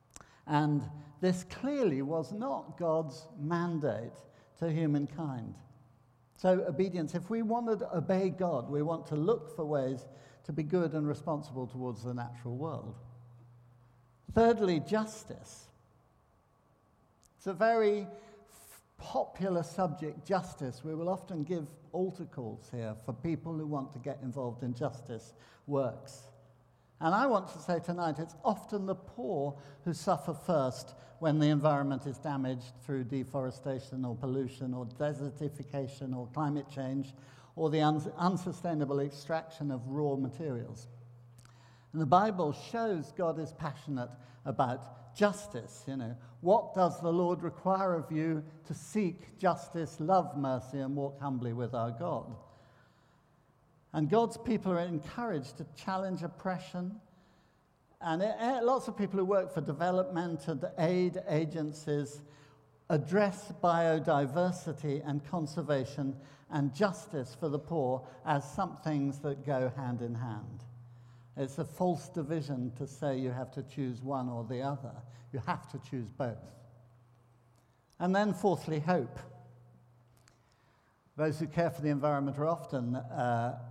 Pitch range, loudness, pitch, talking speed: 130-170 Hz, -34 LUFS, 145 Hz, 135 wpm